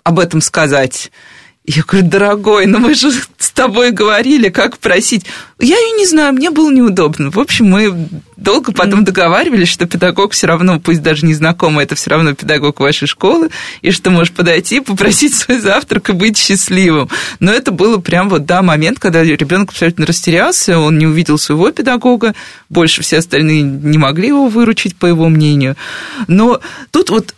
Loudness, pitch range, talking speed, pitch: -10 LUFS, 160-230 Hz, 175 wpm, 185 Hz